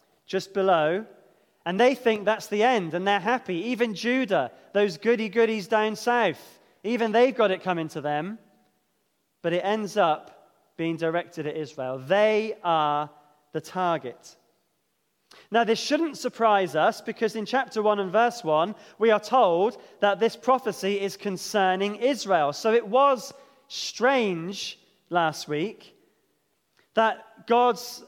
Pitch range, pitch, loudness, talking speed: 175-230 Hz, 210 Hz, -25 LUFS, 140 wpm